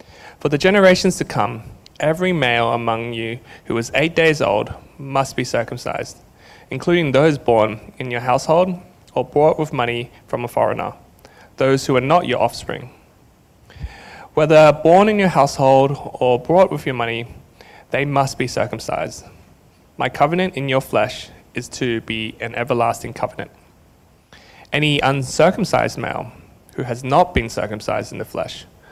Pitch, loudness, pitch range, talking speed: 135 Hz, -18 LUFS, 120-155 Hz, 150 wpm